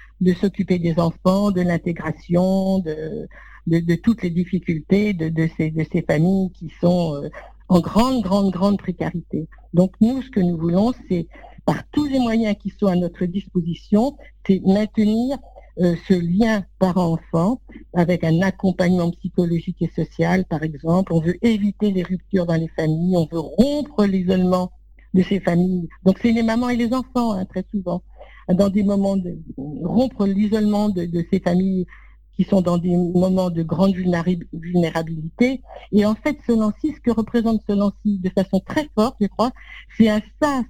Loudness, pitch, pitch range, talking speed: -20 LUFS, 190 Hz, 175-210 Hz, 175 wpm